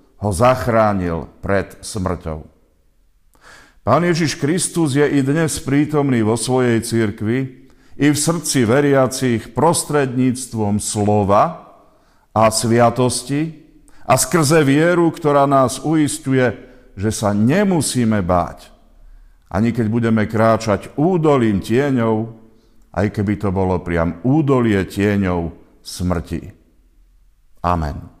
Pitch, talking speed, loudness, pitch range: 115 Hz, 100 wpm, -17 LUFS, 95-140 Hz